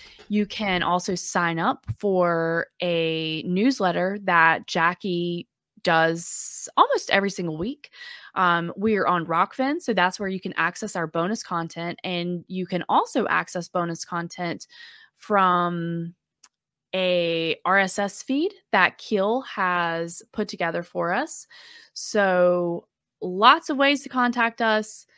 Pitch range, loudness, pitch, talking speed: 170-215 Hz, -23 LUFS, 185 Hz, 130 wpm